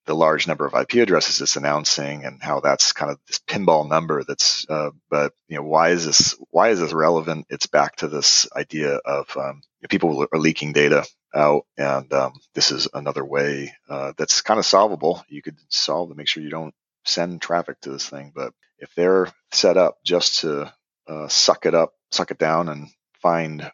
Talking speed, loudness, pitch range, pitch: 200 wpm, -20 LUFS, 75-80 Hz, 75 Hz